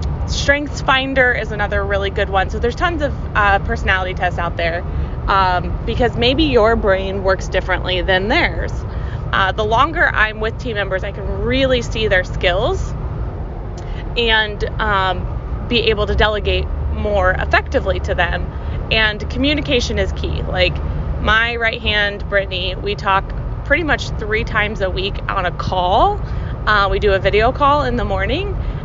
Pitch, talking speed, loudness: 195 Hz, 160 wpm, -17 LUFS